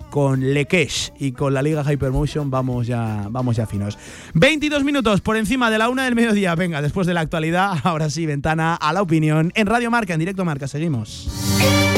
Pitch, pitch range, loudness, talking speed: 155 Hz, 135-190 Hz, -19 LUFS, 195 wpm